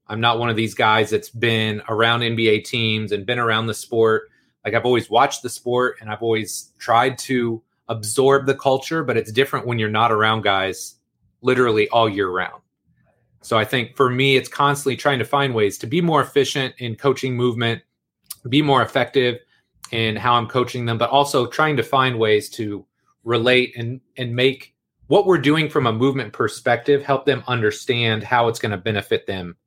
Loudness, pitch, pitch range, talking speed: -19 LUFS, 120 Hz, 110-135 Hz, 190 wpm